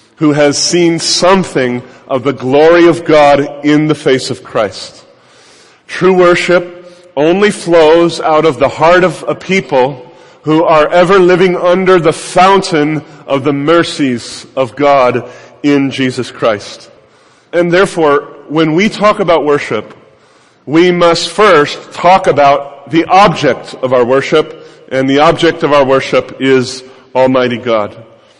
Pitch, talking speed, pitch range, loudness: 150 Hz, 140 wpm, 135-175 Hz, -10 LUFS